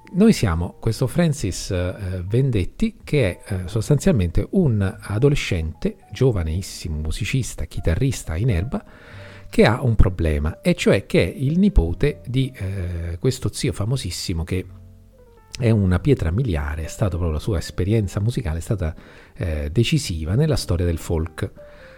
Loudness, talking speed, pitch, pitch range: -22 LUFS, 140 wpm, 100 Hz, 85-125 Hz